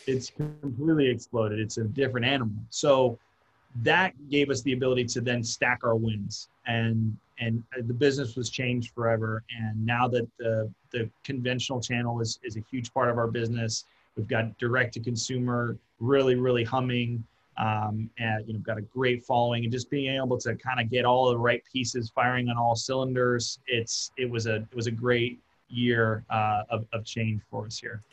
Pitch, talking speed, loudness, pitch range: 120 Hz, 190 wpm, -28 LUFS, 115-125 Hz